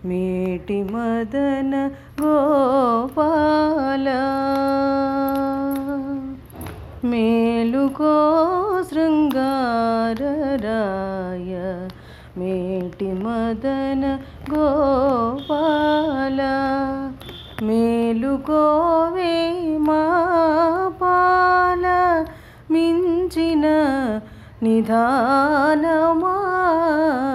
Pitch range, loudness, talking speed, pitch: 235-315 Hz, -19 LUFS, 30 wpm, 275 Hz